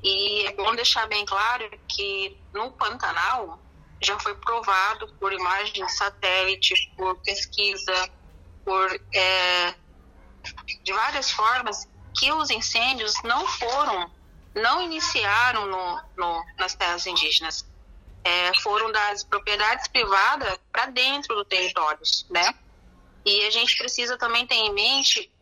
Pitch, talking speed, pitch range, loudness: 205 Hz, 125 wpm, 185-240 Hz, -23 LUFS